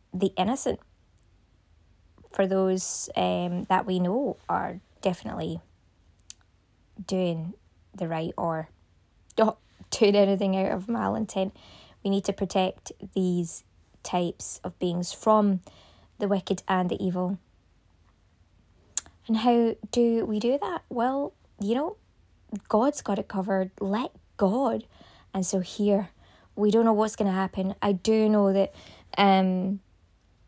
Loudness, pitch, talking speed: -27 LUFS, 190 Hz, 130 wpm